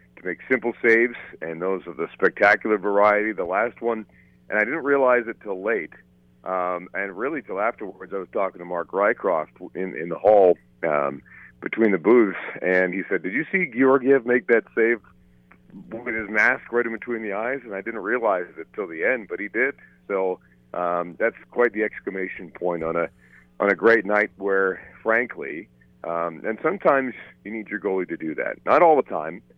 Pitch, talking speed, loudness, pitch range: 95 Hz, 195 wpm, -23 LUFS, 85-115 Hz